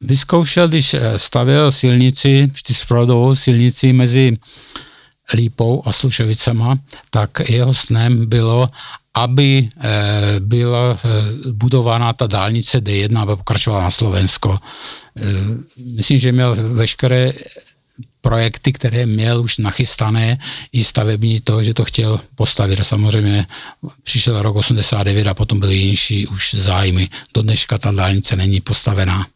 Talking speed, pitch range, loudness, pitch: 115 wpm, 105-125 Hz, -14 LUFS, 115 Hz